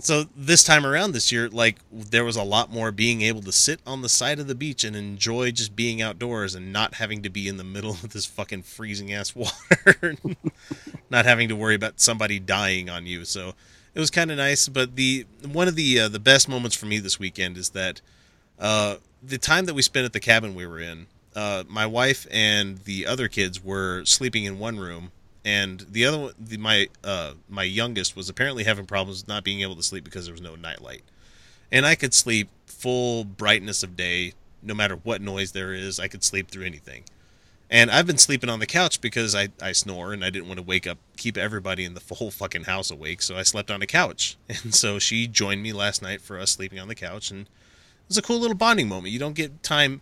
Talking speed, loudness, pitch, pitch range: 235 wpm, -22 LUFS, 105 Hz, 95-120 Hz